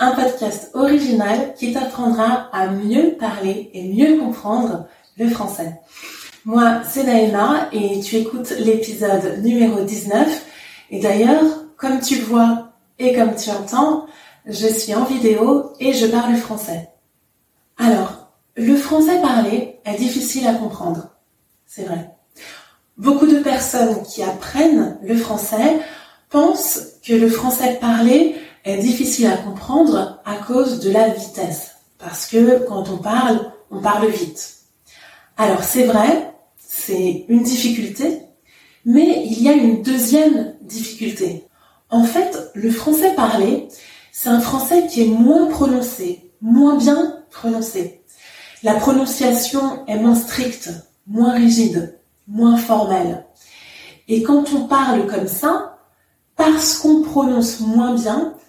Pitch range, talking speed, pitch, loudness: 215-270 Hz, 130 wpm, 235 Hz, -17 LUFS